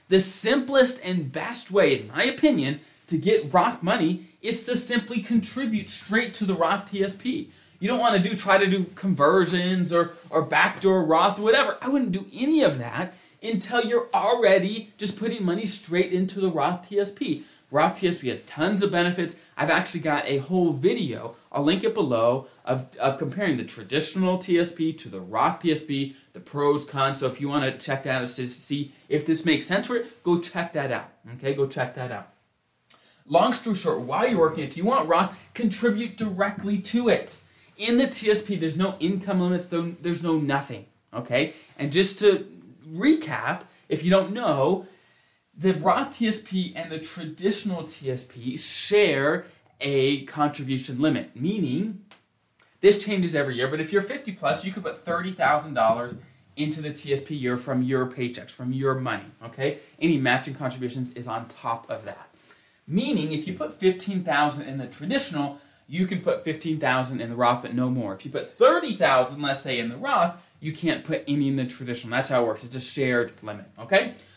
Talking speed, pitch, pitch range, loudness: 185 wpm, 170 Hz, 140-200 Hz, -25 LUFS